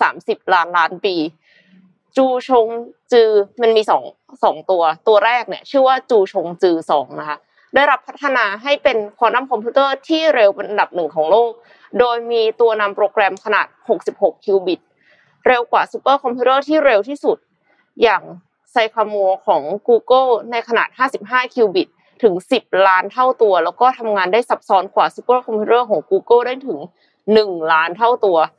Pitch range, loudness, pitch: 200-260 Hz, -16 LUFS, 235 Hz